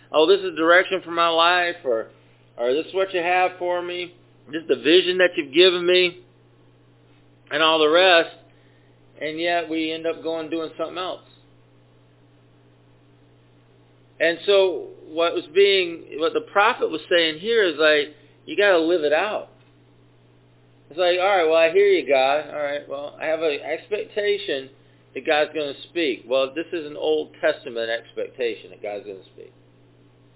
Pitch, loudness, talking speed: 160 Hz, -21 LUFS, 180 wpm